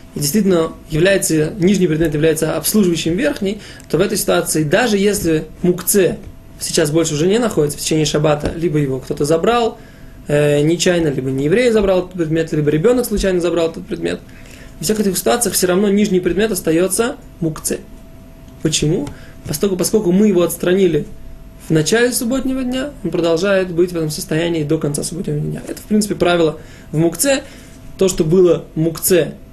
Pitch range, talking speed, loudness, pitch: 160-195 Hz, 165 wpm, -16 LUFS, 175 Hz